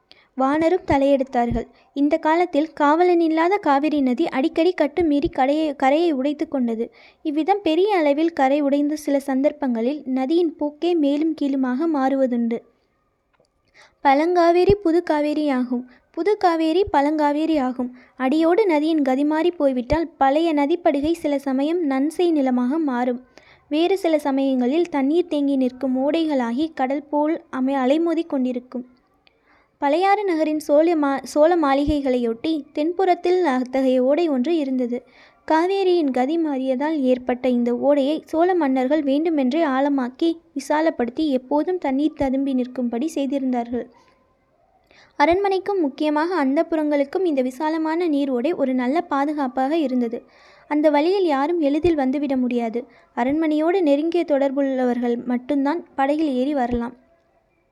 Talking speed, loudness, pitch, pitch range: 110 wpm, -20 LUFS, 290 Hz, 265-320 Hz